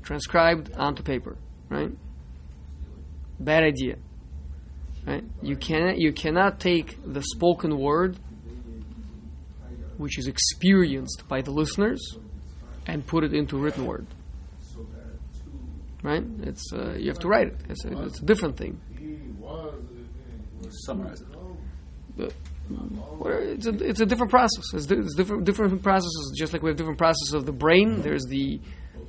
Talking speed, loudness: 130 wpm, -25 LUFS